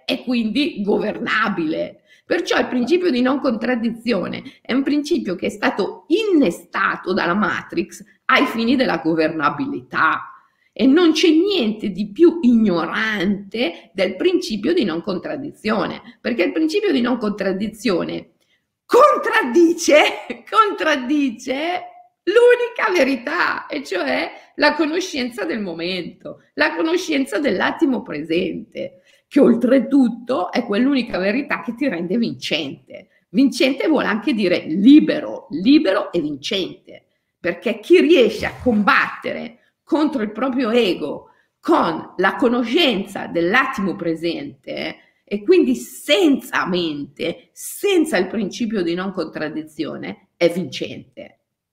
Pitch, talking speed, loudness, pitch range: 255 Hz, 110 wpm, -19 LUFS, 205-305 Hz